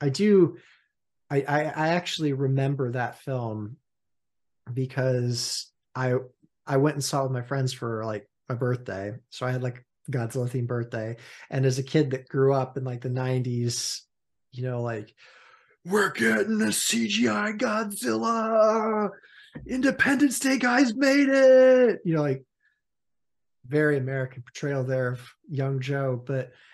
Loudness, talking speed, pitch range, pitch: -25 LUFS, 145 wpm, 125-165 Hz, 135 Hz